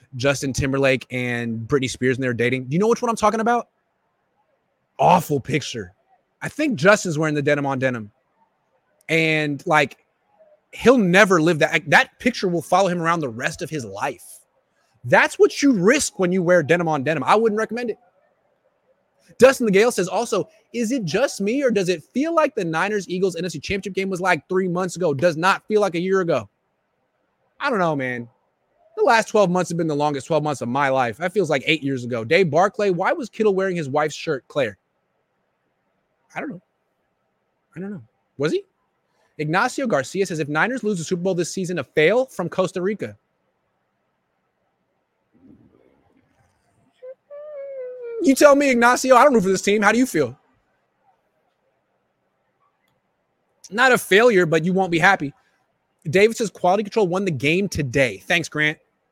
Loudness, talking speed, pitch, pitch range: -20 LUFS, 180 wpm, 185 Hz, 150-220 Hz